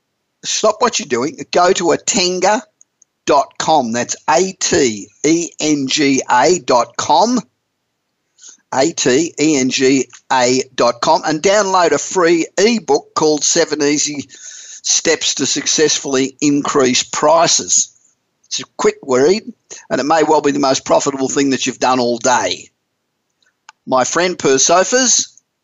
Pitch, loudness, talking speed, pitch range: 150 Hz, -14 LUFS, 130 wpm, 135-190 Hz